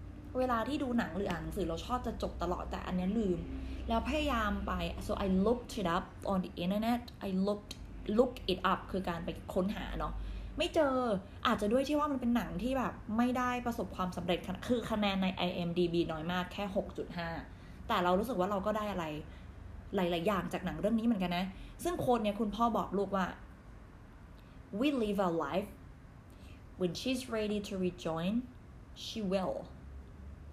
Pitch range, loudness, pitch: 175-230 Hz, -35 LUFS, 195 Hz